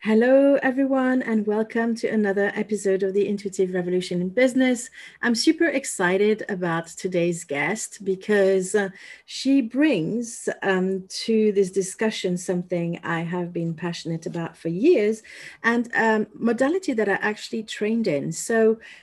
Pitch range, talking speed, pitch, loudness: 185-230 Hz, 135 wpm, 210 Hz, -23 LUFS